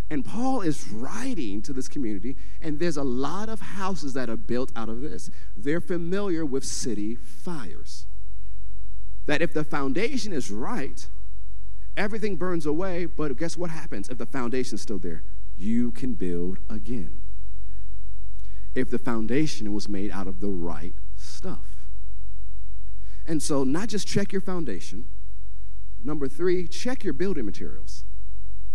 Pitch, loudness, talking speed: 110 Hz, -30 LUFS, 145 wpm